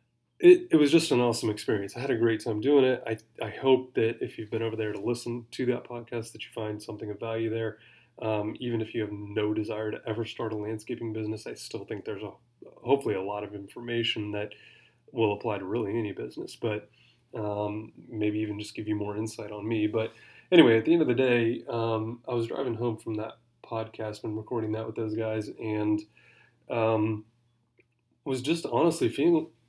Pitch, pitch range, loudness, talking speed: 110 Hz, 110-120 Hz, -29 LUFS, 210 wpm